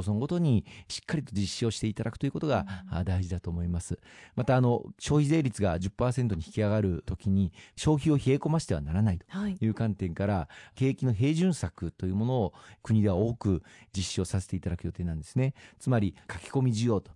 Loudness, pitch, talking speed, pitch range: -30 LUFS, 105 Hz, 405 characters per minute, 95-125 Hz